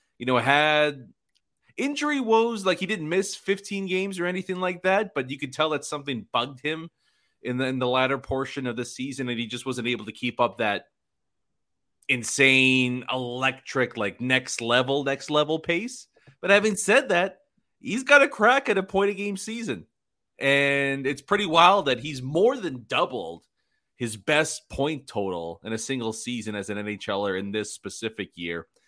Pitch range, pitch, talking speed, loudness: 125-190 Hz, 140 Hz, 180 wpm, -24 LUFS